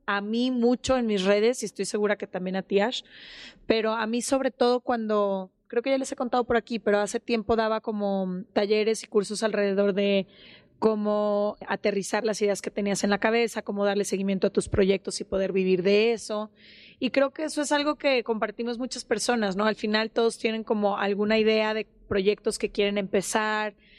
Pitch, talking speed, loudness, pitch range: 215 Hz, 205 wpm, -26 LUFS, 205-235 Hz